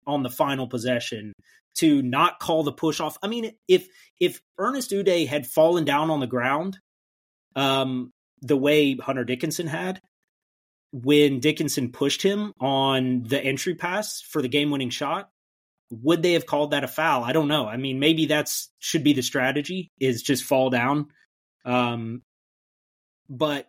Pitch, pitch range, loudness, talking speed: 145 Hz, 130-160 Hz, -24 LUFS, 165 wpm